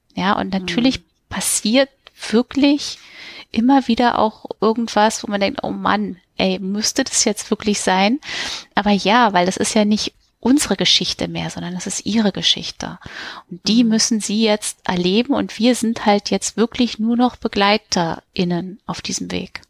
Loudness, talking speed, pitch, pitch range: -18 LUFS, 160 wpm, 215 Hz, 190-235 Hz